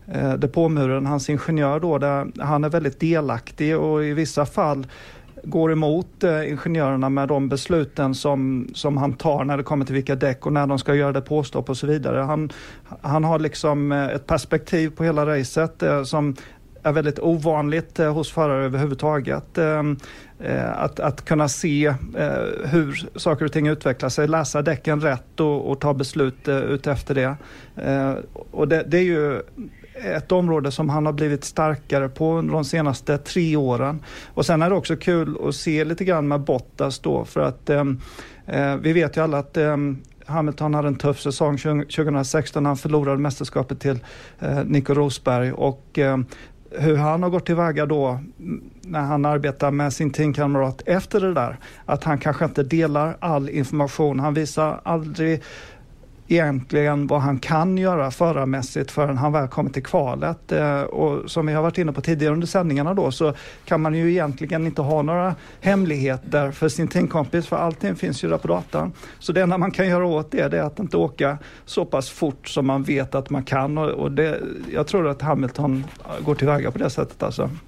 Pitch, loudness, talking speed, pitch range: 150 Hz, -22 LUFS, 180 wpm, 140-160 Hz